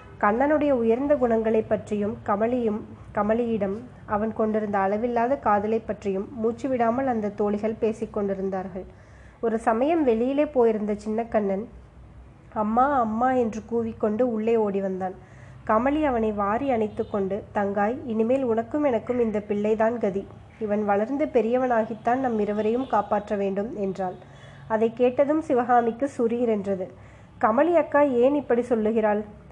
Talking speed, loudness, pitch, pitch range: 120 wpm, -24 LUFS, 225 Hz, 210-245 Hz